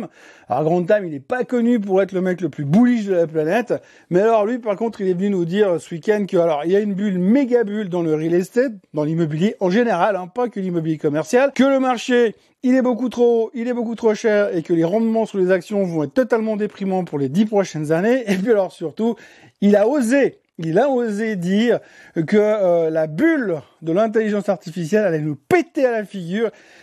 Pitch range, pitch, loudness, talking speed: 175-235 Hz, 205 Hz, -19 LUFS, 235 wpm